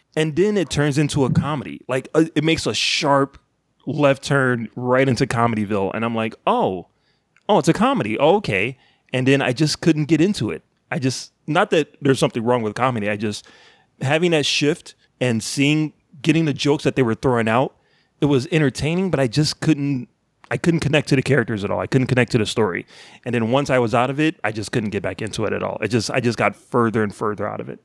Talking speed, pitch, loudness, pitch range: 235 wpm, 135 Hz, -20 LUFS, 120-150 Hz